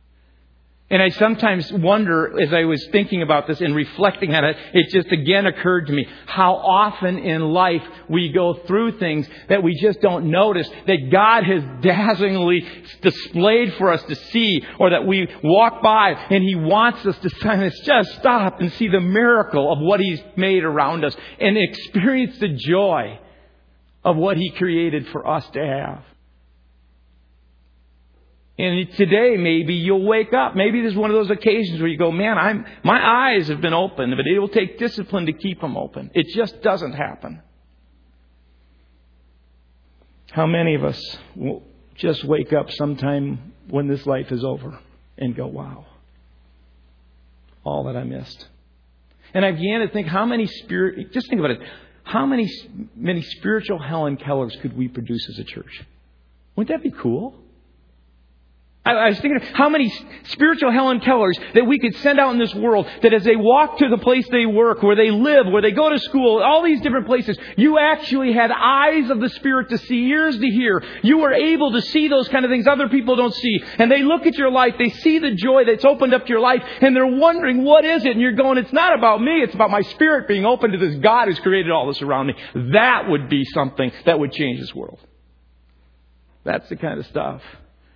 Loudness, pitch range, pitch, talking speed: -18 LUFS, 140-235 Hz, 190 Hz, 190 wpm